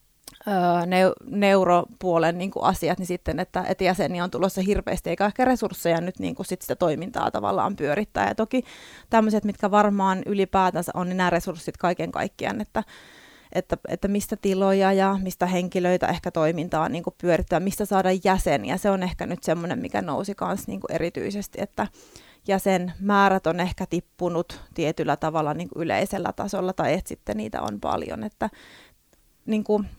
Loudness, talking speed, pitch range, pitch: -24 LUFS, 160 wpm, 170-195 Hz, 185 Hz